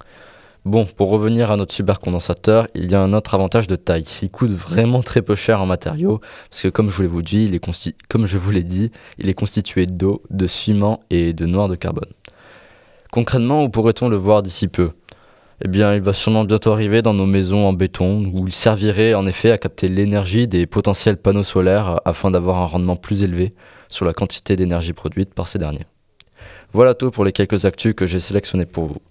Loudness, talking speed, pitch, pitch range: -18 LUFS, 215 wpm, 100 Hz, 90-110 Hz